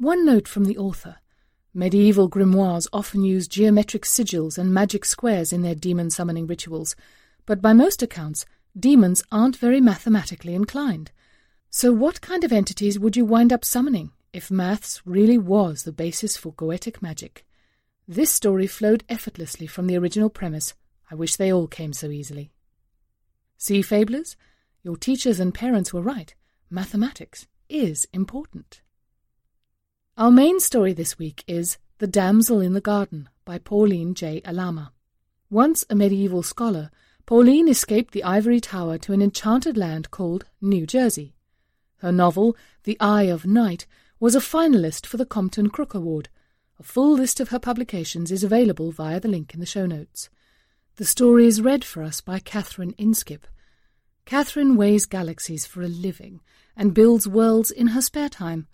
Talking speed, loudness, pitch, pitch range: 160 wpm, -21 LUFS, 200 Hz, 175-230 Hz